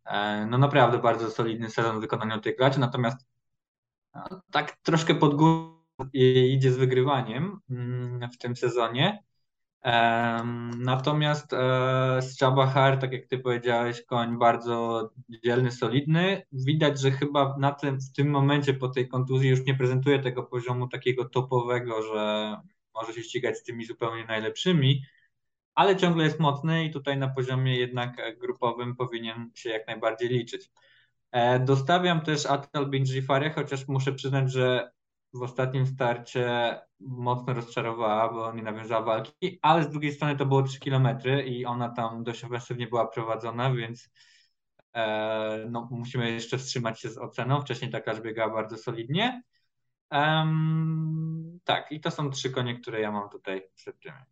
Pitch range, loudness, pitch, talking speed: 120-140 Hz, -27 LUFS, 125 Hz, 140 wpm